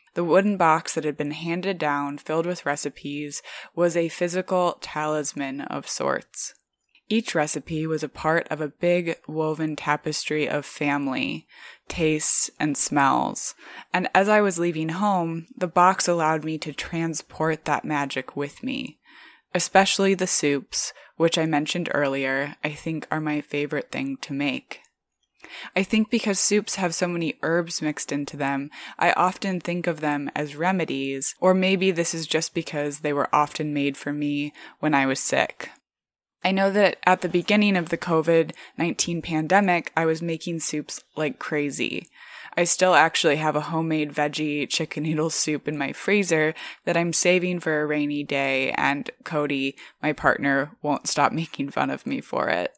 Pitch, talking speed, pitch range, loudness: 160 Hz, 165 wpm, 145-175 Hz, -24 LUFS